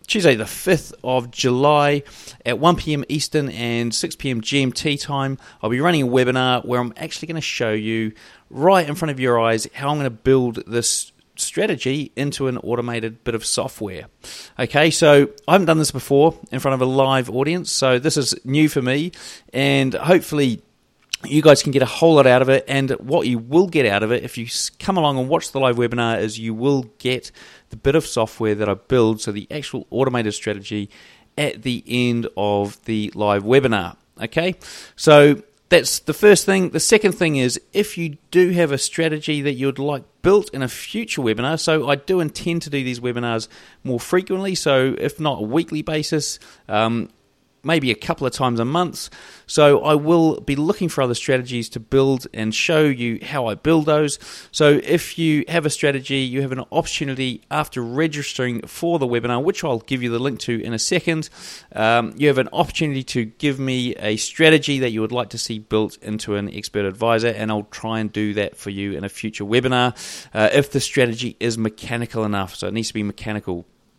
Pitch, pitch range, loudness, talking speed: 130 Hz, 115-150 Hz, -19 LUFS, 205 wpm